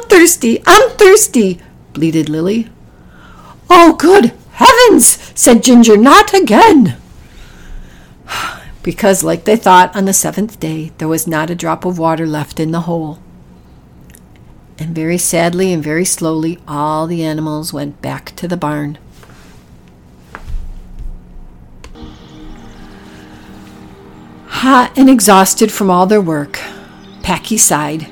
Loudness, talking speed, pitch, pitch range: -10 LUFS, 115 wpm, 165 Hz, 145-215 Hz